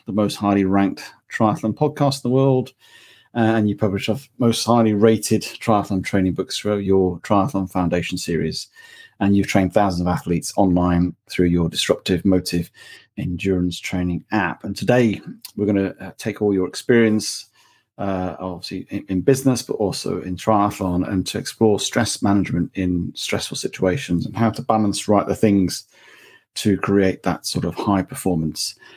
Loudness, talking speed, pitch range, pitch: -20 LUFS, 165 wpm, 90-110 Hz, 100 Hz